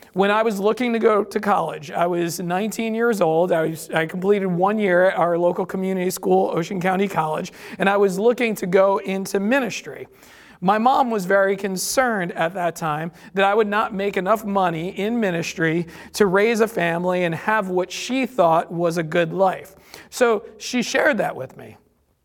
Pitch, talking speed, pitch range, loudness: 195 Hz, 190 wpm, 175-220 Hz, -20 LUFS